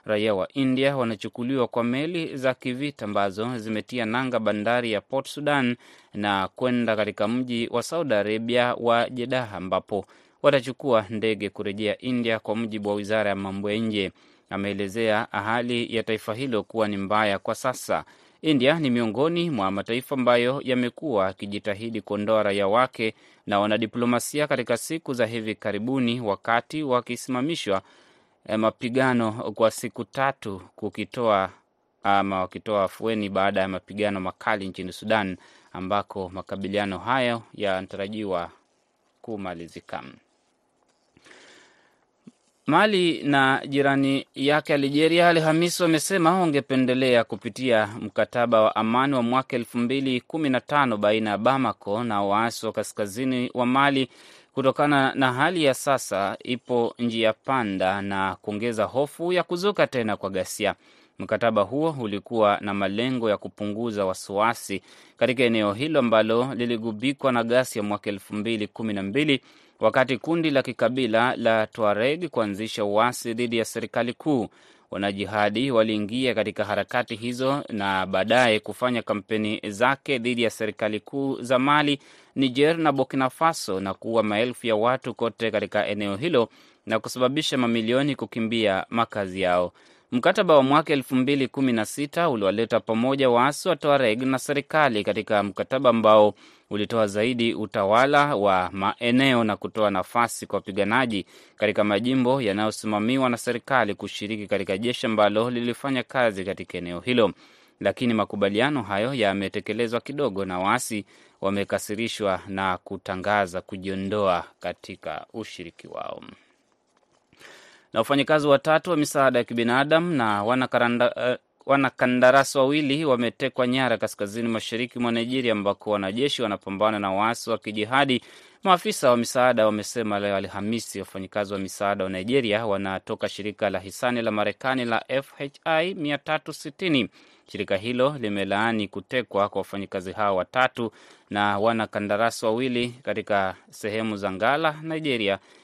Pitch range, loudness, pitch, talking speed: 105-130 Hz, -24 LUFS, 115 Hz, 130 wpm